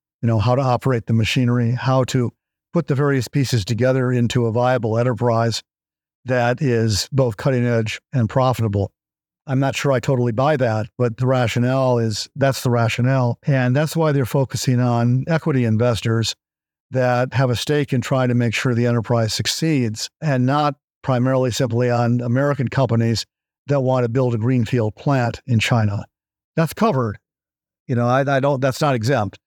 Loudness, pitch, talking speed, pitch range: -19 LUFS, 125 Hz, 175 wpm, 115-135 Hz